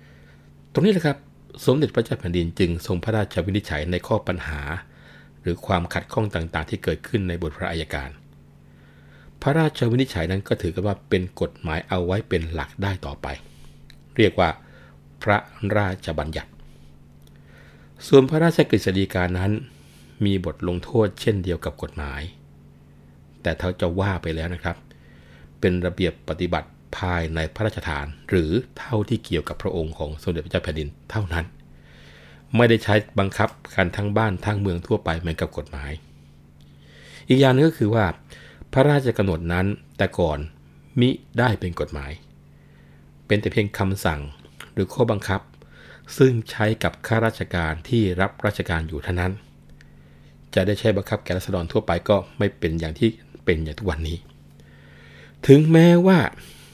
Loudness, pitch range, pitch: -23 LUFS, 75-105 Hz, 85 Hz